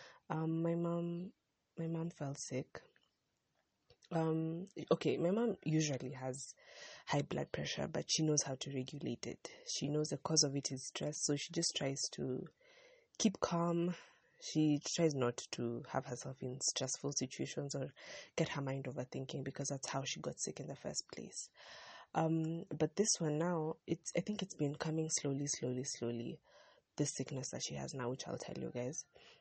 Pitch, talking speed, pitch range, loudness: 155 Hz, 180 wpm, 135-170 Hz, -39 LUFS